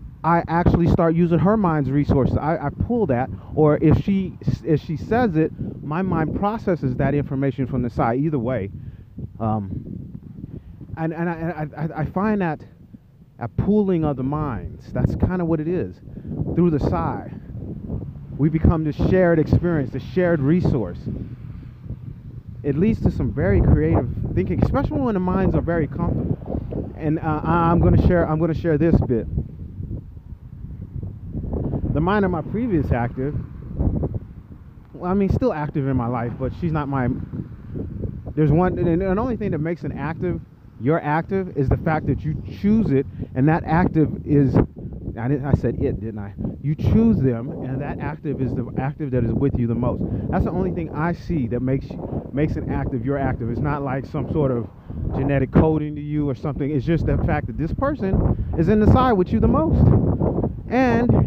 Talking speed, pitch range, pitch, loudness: 185 wpm, 125-165 Hz, 145 Hz, -21 LUFS